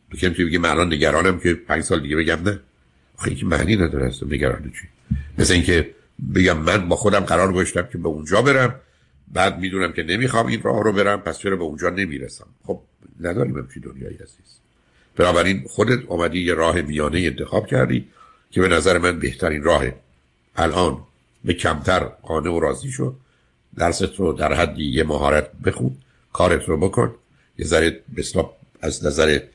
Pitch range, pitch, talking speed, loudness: 70-95 Hz, 85 Hz, 165 wpm, -20 LUFS